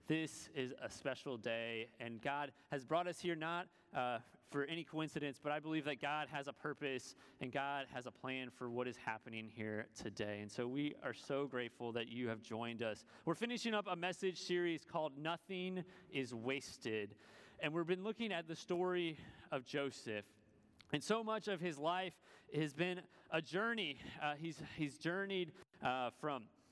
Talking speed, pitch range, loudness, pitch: 180 wpm, 125-170 Hz, -43 LUFS, 145 Hz